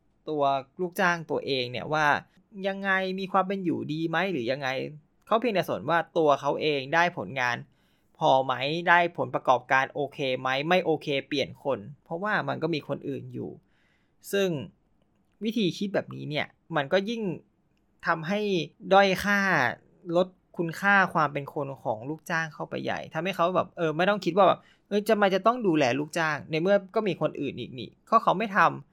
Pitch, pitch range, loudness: 165 Hz, 145-190 Hz, -27 LUFS